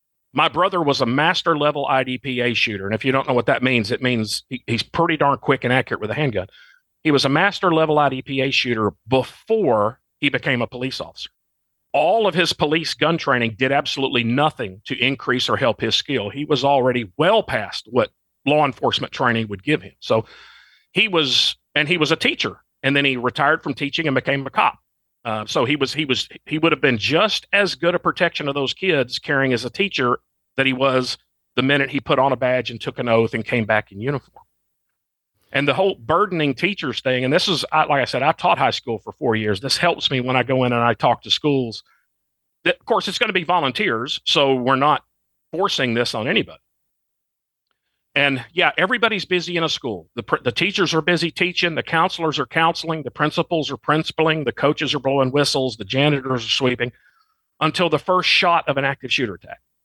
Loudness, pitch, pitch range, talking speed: -19 LUFS, 140 Hz, 125-160 Hz, 210 wpm